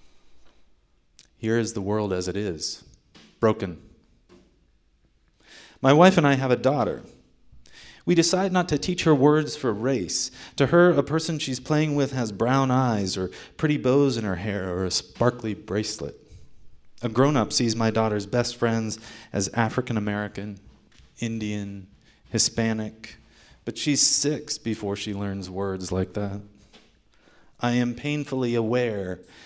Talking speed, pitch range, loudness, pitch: 145 wpm, 100-135 Hz, -24 LUFS, 115 Hz